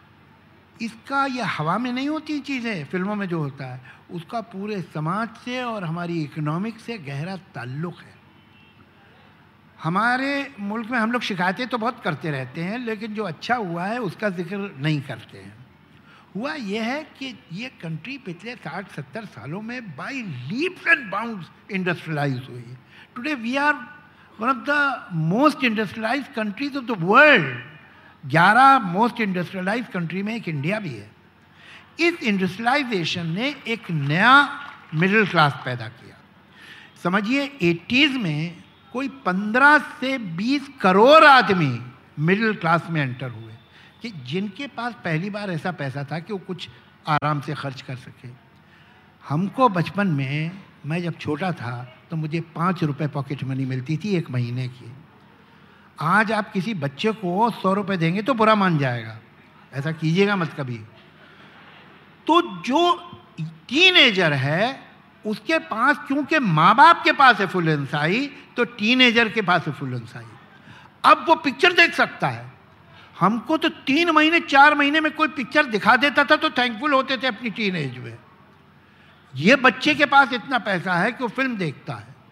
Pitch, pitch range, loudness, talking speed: 200 Hz, 155-255 Hz, -20 LUFS, 155 wpm